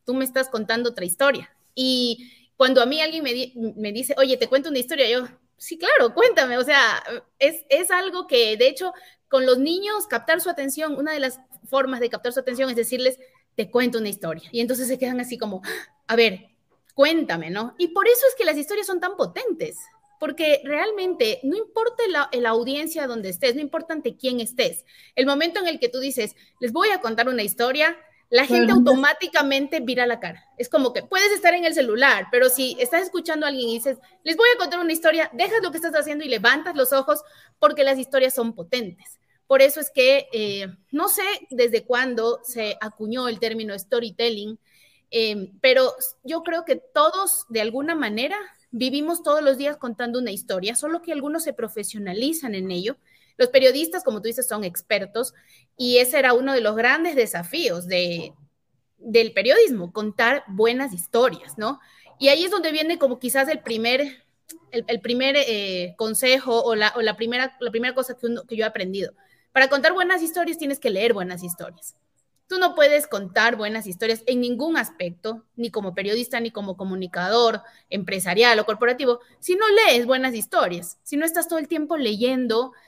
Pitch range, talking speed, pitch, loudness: 230-310 Hz, 195 wpm, 255 Hz, -21 LUFS